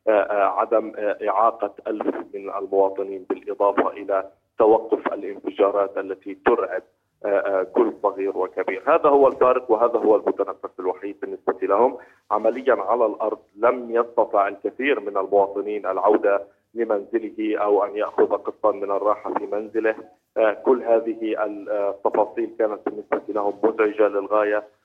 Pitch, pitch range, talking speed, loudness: 105 Hz, 100-115 Hz, 120 wpm, -22 LUFS